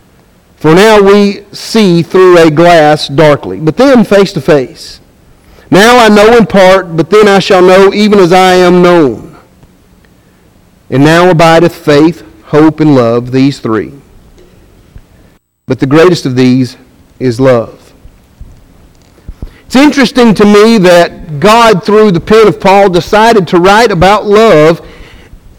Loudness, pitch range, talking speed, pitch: -5 LUFS, 125-200 Hz, 140 wpm, 170 Hz